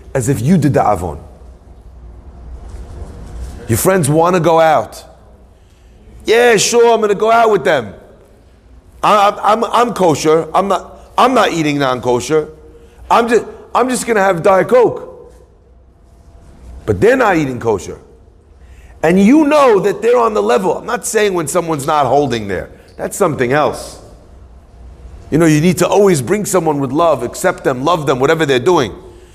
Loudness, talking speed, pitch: -13 LUFS, 170 wpm, 150 Hz